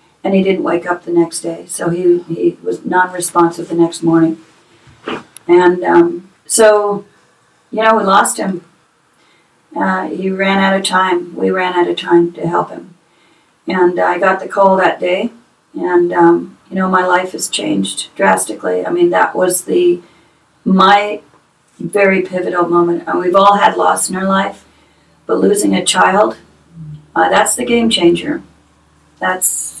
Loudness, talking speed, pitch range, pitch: -13 LUFS, 165 wpm, 170-195 Hz, 180 Hz